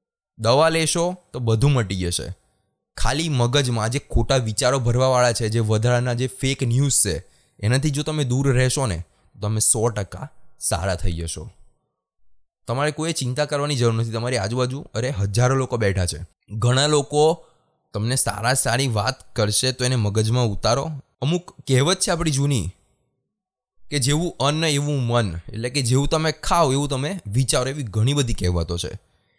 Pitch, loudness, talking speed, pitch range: 125 Hz, -21 LUFS, 160 wpm, 110-145 Hz